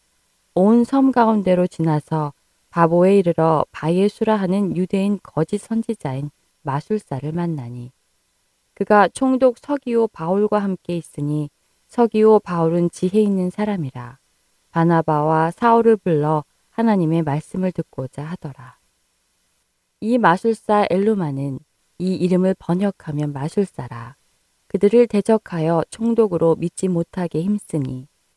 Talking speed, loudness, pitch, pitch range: 270 characters per minute, -19 LUFS, 175 Hz, 155-210 Hz